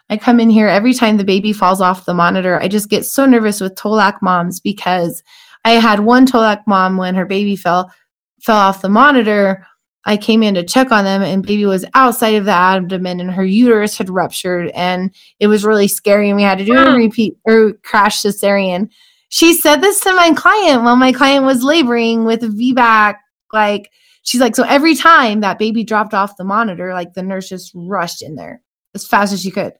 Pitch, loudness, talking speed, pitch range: 210 Hz, -12 LUFS, 210 wpm, 190-240 Hz